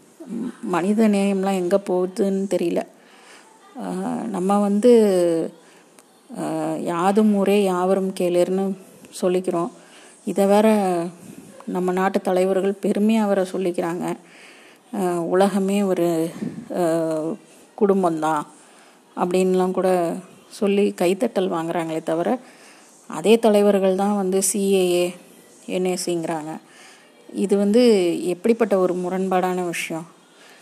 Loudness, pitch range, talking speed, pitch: -21 LUFS, 175-200 Hz, 80 wpm, 190 Hz